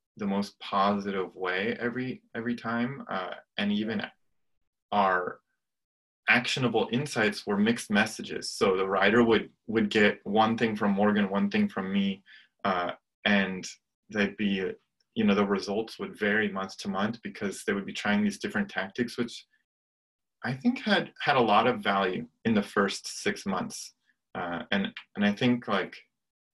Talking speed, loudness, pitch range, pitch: 160 wpm, -28 LUFS, 100-120 Hz, 105 Hz